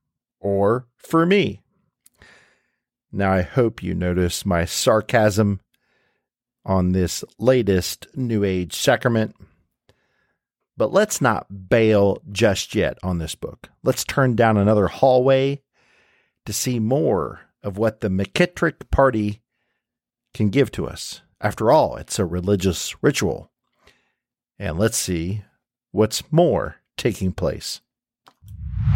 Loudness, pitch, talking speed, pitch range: -21 LUFS, 105 Hz, 115 wpm, 95-120 Hz